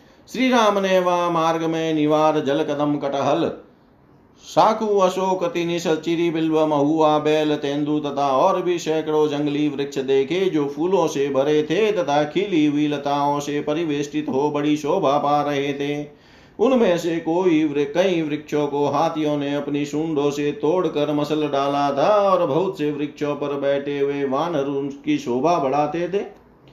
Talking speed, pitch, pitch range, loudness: 145 wpm, 150 Hz, 145-165 Hz, -20 LUFS